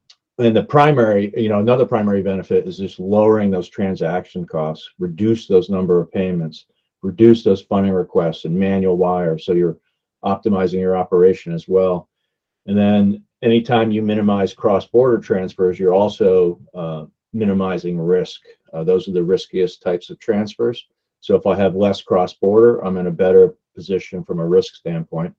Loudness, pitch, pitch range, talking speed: -17 LUFS, 95 Hz, 90-115 Hz, 170 wpm